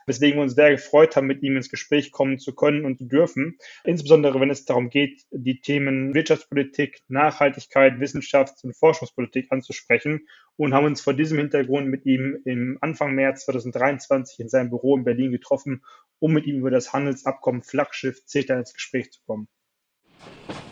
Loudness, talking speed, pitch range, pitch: -22 LUFS, 170 wpm, 130-145 Hz, 135 Hz